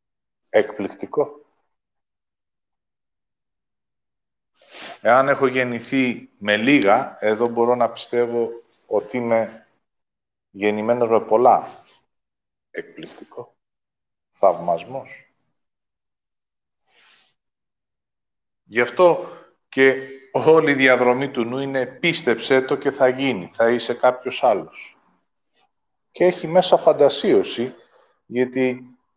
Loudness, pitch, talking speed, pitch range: -19 LUFS, 125 Hz, 80 wpm, 115-135 Hz